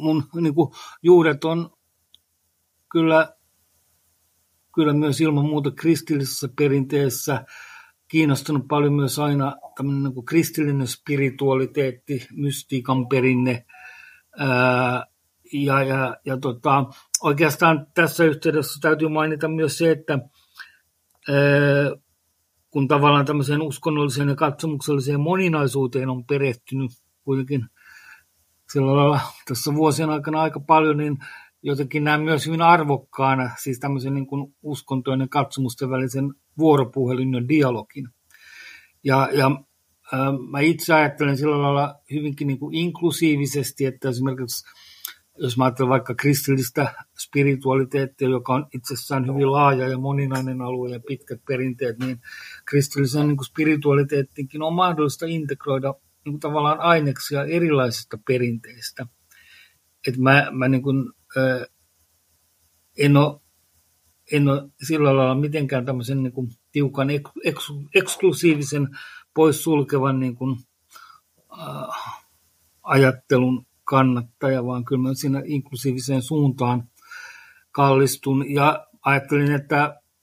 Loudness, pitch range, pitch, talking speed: -21 LUFS, 130-150 Hz, 140 Hz, 105 wpm